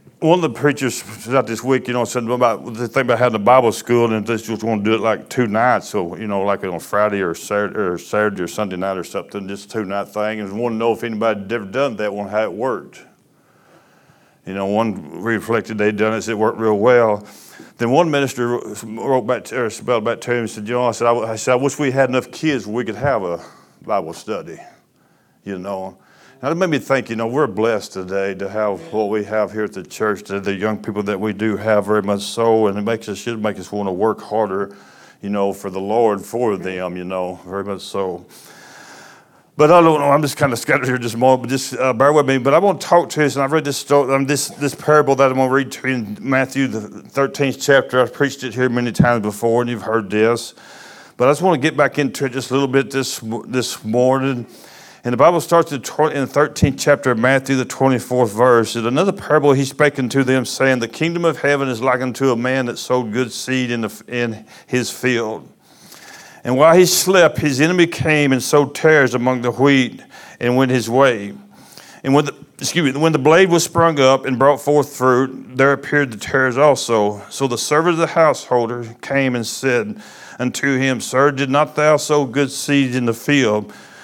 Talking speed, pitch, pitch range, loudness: 240 wpm, 125 Hz, 110-140 Hz, -17 LUFS